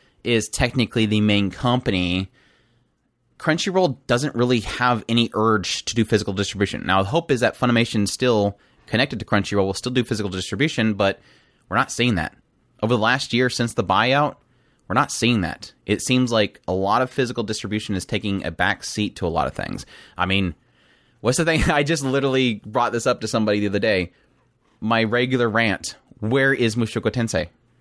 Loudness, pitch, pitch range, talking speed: -21 LUFS, 115 Hz, 100-125 Hz, 190 wpm